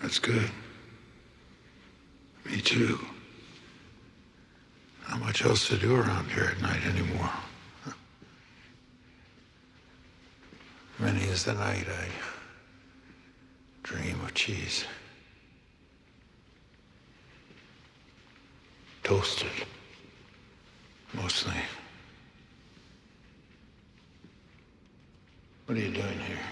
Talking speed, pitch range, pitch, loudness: 70 wpm, 90-115 Hz, 100 Hz, -30 LUFS